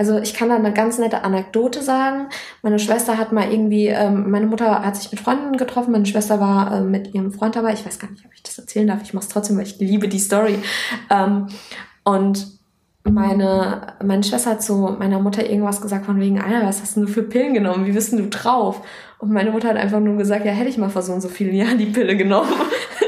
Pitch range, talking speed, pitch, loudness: 200-225 Hz, 245 wpm, 210 Hz, -19 LUFS